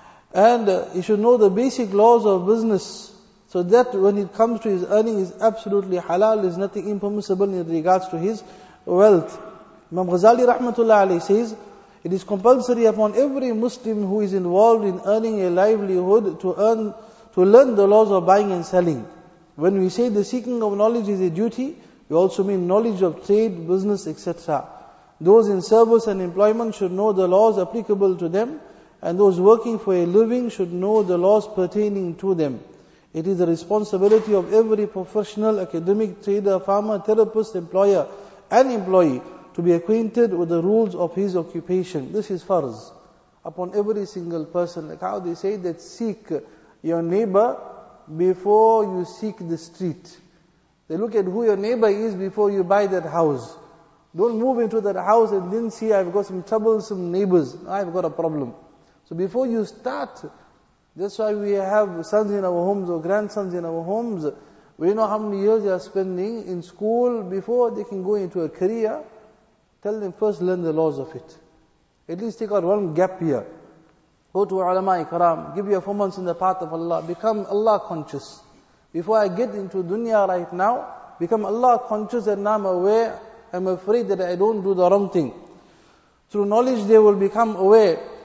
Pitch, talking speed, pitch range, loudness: 200 Hz, 180 wpm, 180-220 Hz, -20 LUFS